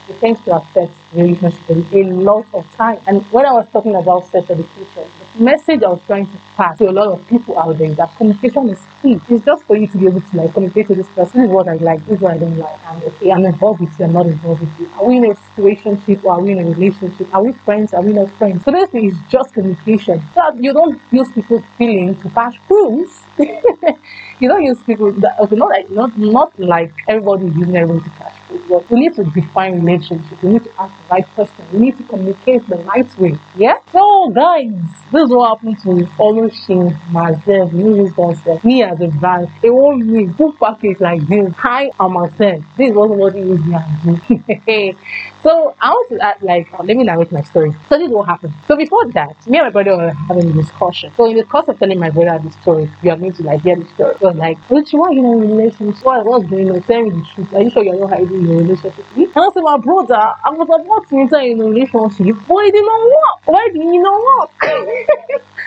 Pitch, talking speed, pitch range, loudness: 200 Hz, 245 wpm, 175-240 Hz, -12 LUFS